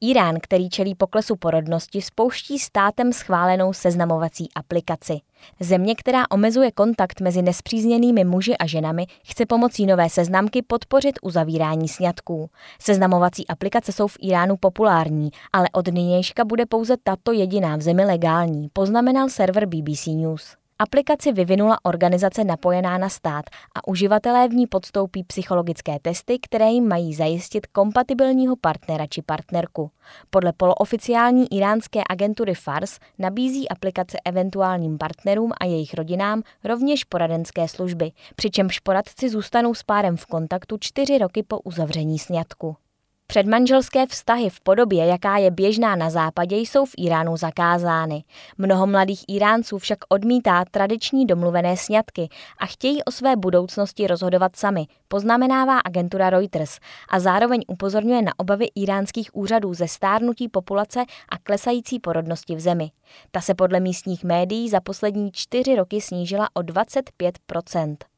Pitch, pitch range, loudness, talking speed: 190 Hz, 175-225 Hz, -21 LUFS, 135 wpm